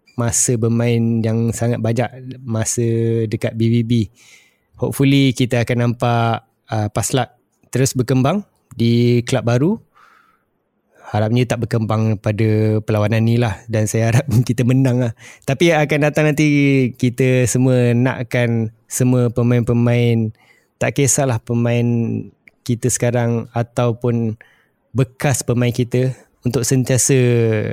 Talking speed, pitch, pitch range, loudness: 115 wpm, 120 Hz, 115-130 Hz, -17 LUFS